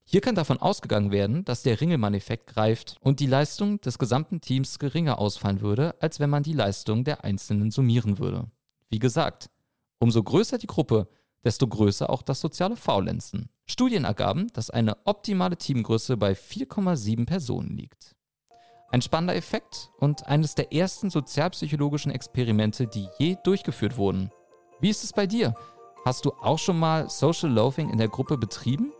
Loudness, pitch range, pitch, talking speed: -26 LUFS, 115-165 Hz, 135 Hz, 160 wpm